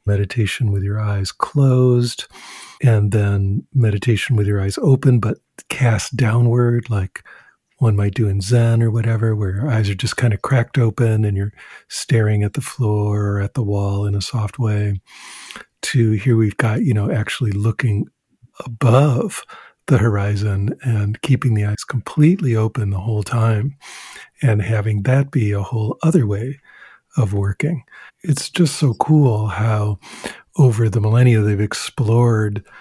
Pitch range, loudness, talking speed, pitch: 105-125 Hz, -18 LUFS, 155 wpm, 115 Hz